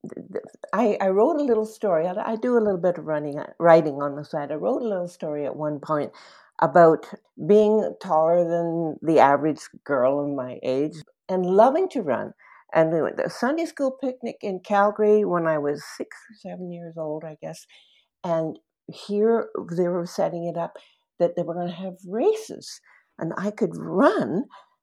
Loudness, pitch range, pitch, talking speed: -23 LUFS, 155-210 Hz, 175 Hz, 180 wpm